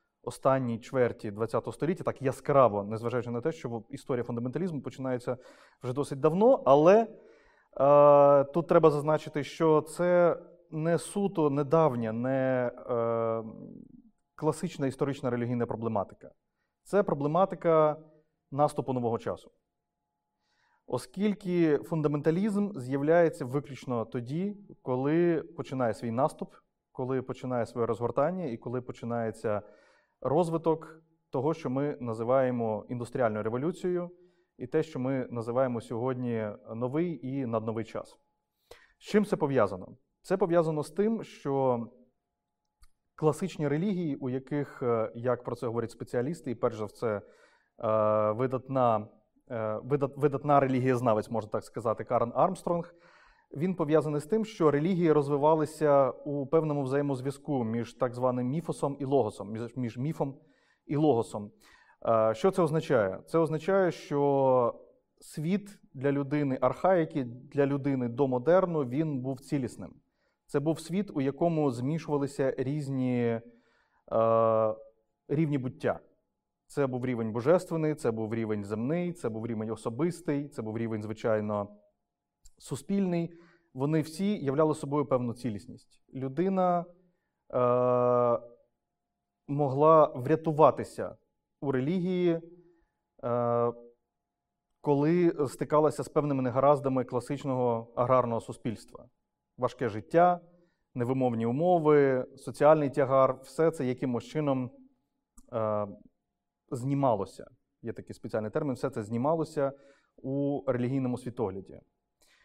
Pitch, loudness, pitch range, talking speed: 140 Hz, -29 LUFS, 120-160 Hz, 110 wpm